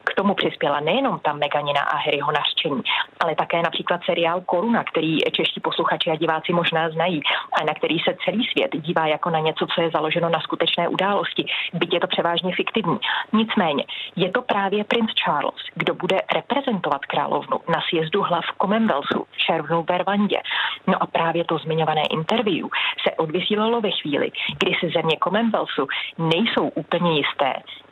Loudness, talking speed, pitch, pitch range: -21 LUFS, 165 wpm, 170 Hz, 160-200 Hz